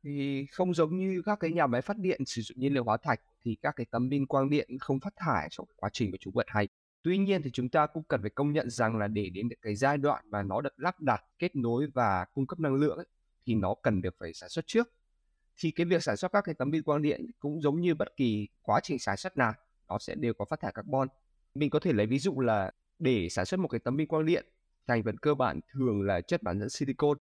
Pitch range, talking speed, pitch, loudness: 115-160 Hz, 275 wpm, 135 Hz, -31 LUFS